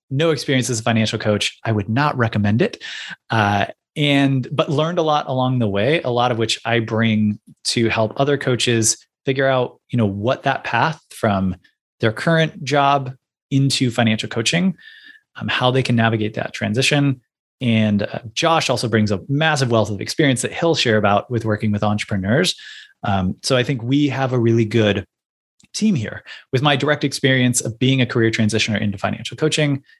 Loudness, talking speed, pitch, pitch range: -19 LUFS, 185 wpm, 125 Hz, 110-140 Hz